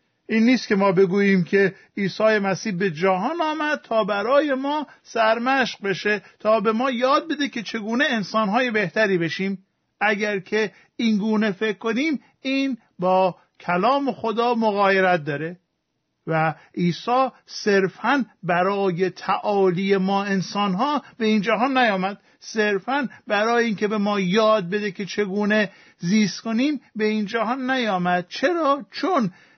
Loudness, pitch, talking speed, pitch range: -22 LUFS, 215 Hz, 130 wpm, 195-240 Hz